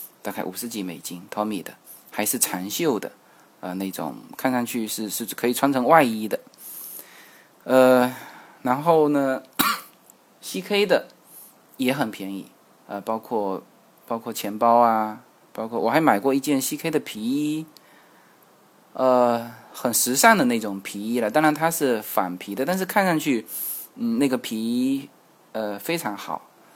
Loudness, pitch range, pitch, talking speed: -23 LUFS, 110-150 Hz, 125 Hz, 215 characters per minute